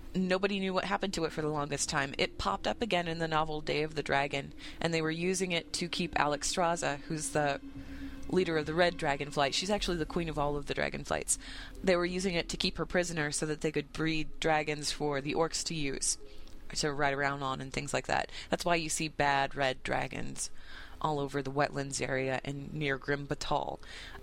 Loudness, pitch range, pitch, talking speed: -32 LUFS, 140-170 Hz, 150 Hz, 225 wpm